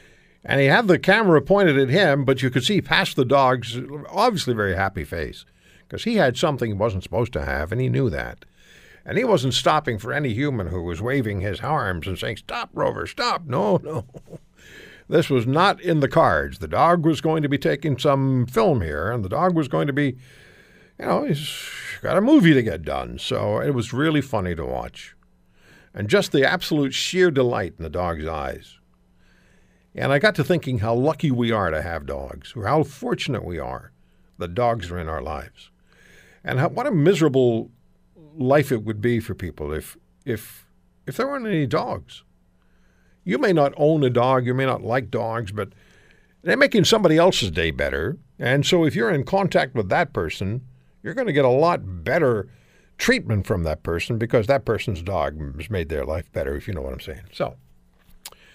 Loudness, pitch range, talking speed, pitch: -21 LUFS, 95-155 Hz, 200 wpm, 130 Hz